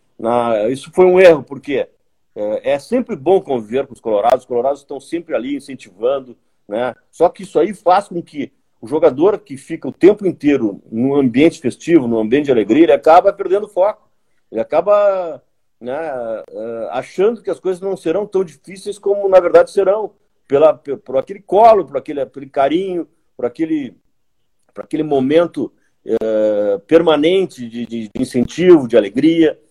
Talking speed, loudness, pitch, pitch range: 170 wpm, -15 LUFS, 175 Hz, 140-205 Hz